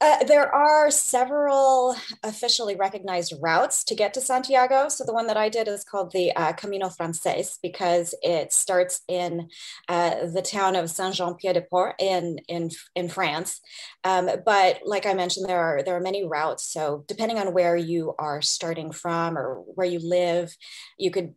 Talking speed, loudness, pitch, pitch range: 185 wpm, -24 LUFS, 185 Hz, 175-215 Hz